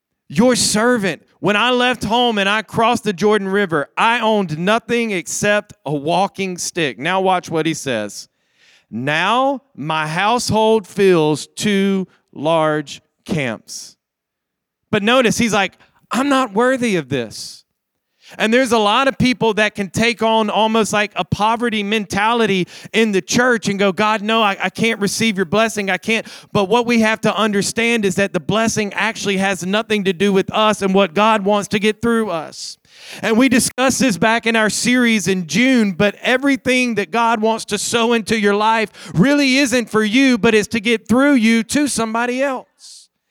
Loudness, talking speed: -16 LUFS, 175 wpm